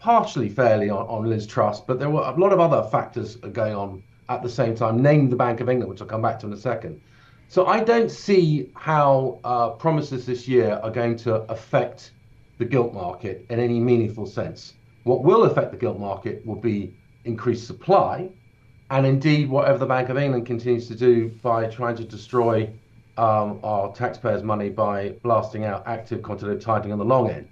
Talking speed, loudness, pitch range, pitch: 200 wpm, -22 LUFS, 110-130 Hz, 120 Hz